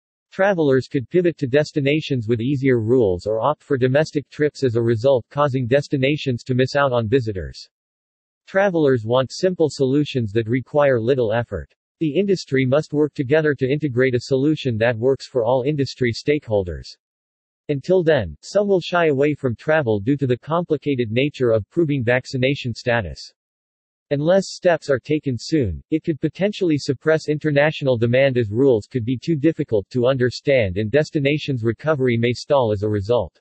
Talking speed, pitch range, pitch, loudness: 160 wpm, 120-150 Hz, 135 Hz, -20 LUFS